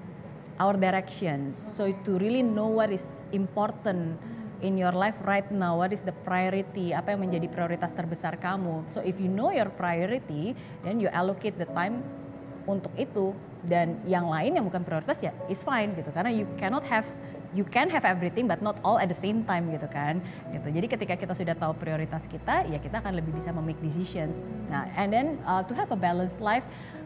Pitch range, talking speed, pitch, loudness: 170-200 Hz, 195 wpm, 185 Hz, -29 LUFS